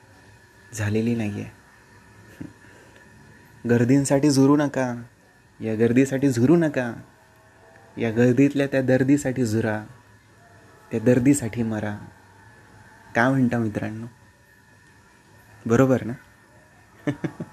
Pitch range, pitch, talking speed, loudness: 105-130 Hz, 115 Hz, 80 wpm, -22 LUFS